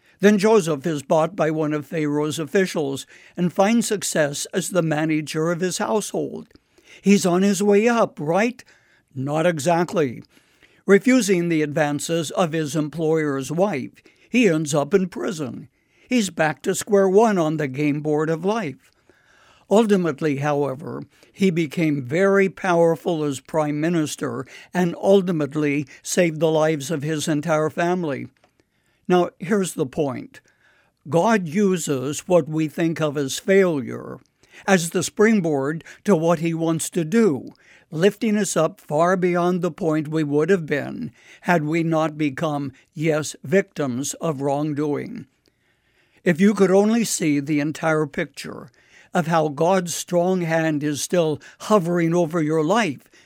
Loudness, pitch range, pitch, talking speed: -21 LUFS, 155-190 Hz, 165 Hz, 140 wpm